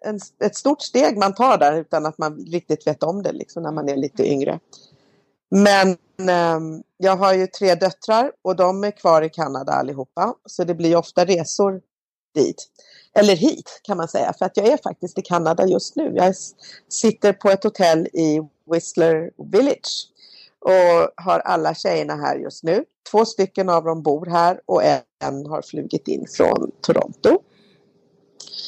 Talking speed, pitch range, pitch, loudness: 170 wpm, 165-200 Hz, 180 Hz, -19 LUFS